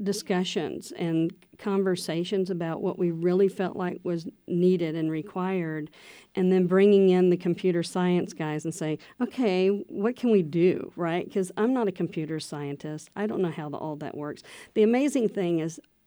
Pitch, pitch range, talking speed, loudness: 180 Hz, 165-195 Hz, 175 wpm, -27 LUFS